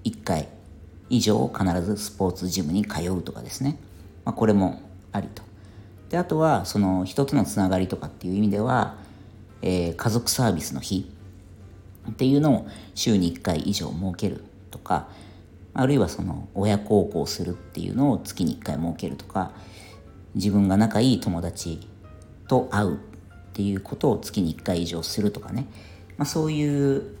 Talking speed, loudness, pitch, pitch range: 300 characters per minute, -25 LUFS, 100 Hz, 90-110 Hz